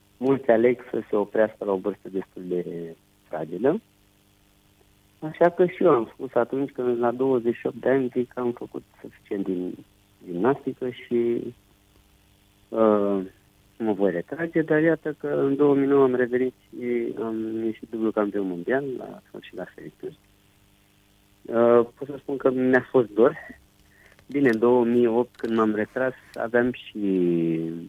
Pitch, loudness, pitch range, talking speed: 110 Hz, -24 LUFS, 100-125 Hz, 145 wpm